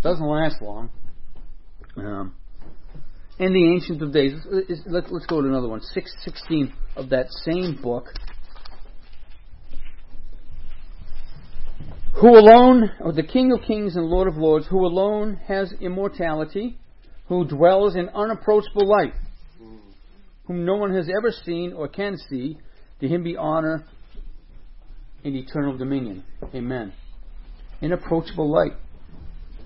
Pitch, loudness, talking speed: 155 Hz, -20 LUFS, 120 wpm